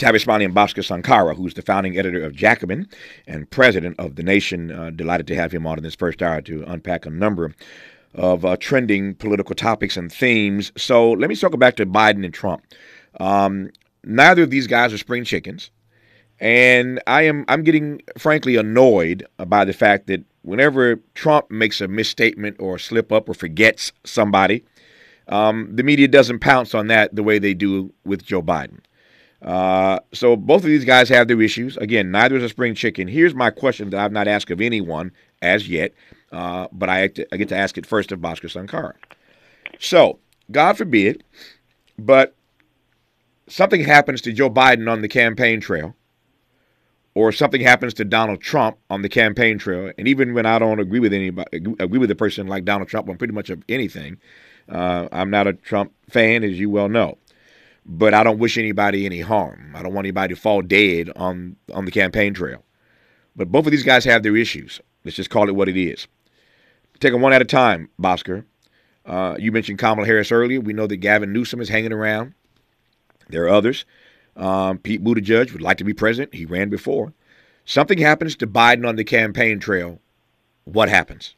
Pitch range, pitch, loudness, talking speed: 95-120 Hz, 105 Hz, -17 LUFS, 195 wpm